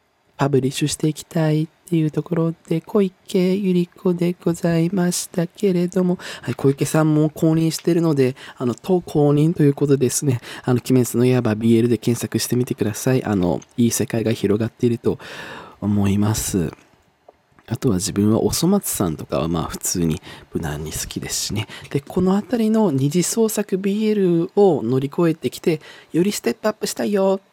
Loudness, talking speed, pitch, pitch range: -20 LUFS, 355 characters per minute, 155 Hz, 120-180 Hz